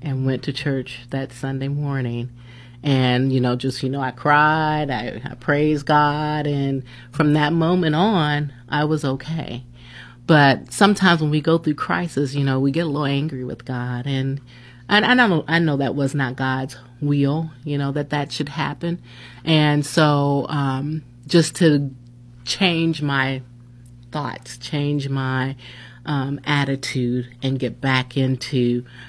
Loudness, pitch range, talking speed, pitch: -20 LUFS, 125-150 Hz, 155 wpm, 135 Hz